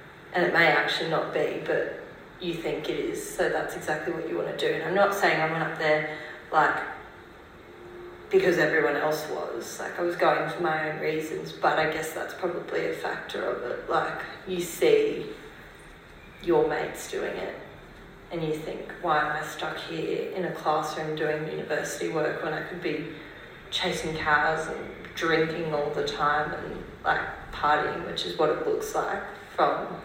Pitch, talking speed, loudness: 175 Hz, 180 wpm, -27 LUFS